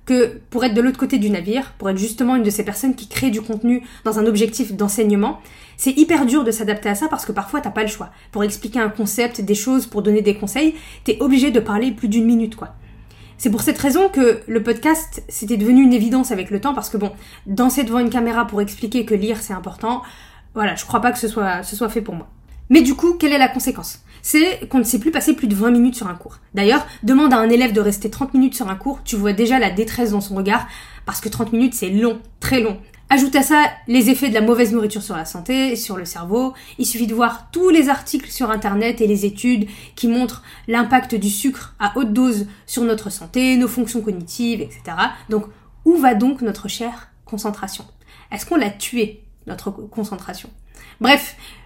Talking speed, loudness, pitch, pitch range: 230 wpm, -18 LUFS, 230 Hz, 210-255 Hz